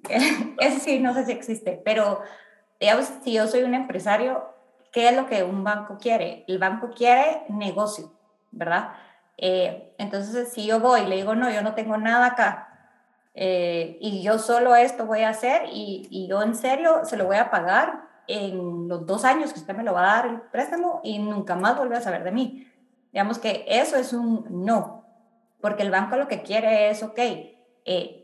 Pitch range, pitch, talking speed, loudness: 200-245 Hz, 220 Hz, 200 wpm, -23 LUFS